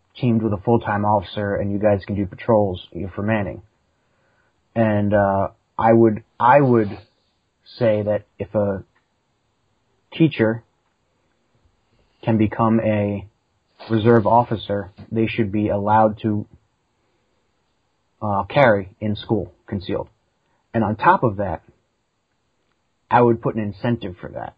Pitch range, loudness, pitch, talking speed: 100-115 Hz, -20 LUFS, 105 Hz, 125 wpm